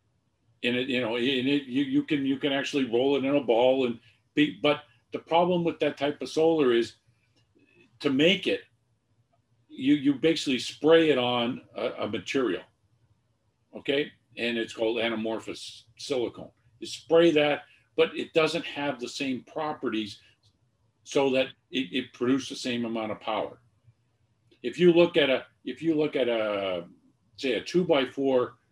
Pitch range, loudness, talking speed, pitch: 115-150 Hz, -27 LUFS, 170 wpm, 125 Hz